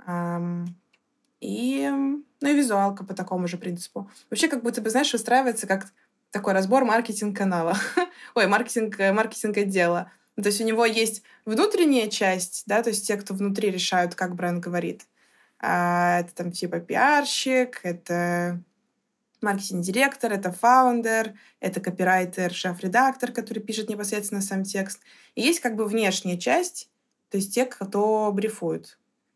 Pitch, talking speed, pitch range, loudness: 210 Hz, 140 wpm, 185-240 Hz, -24 LUFS